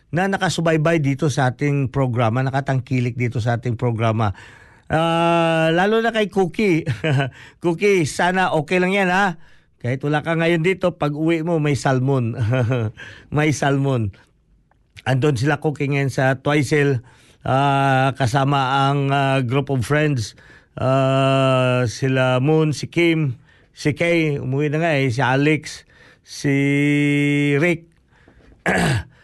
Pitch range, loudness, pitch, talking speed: 130-160 Hz, -19 LUFS, 140 Hz, 125 wpm